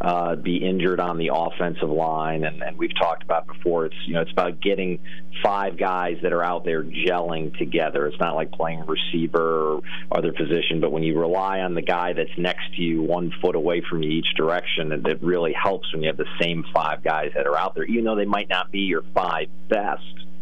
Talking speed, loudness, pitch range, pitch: 225 wpm, -24 LUFS, 80-90 Hz, 85 Hz